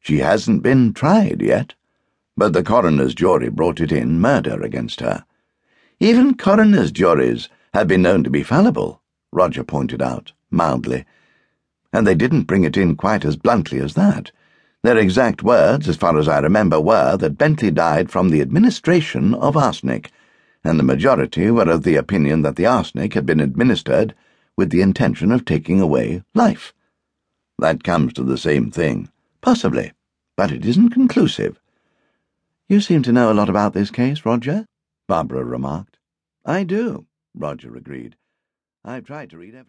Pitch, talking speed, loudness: 130 Hz, 165 wpm, -17 LUFS